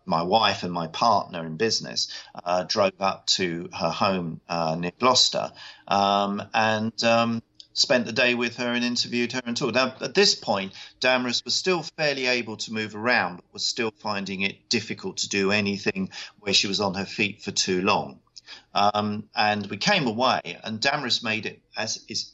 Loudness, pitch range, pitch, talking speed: -24 LUFS, 100-120 Hz, 110 Hz, 190 wpm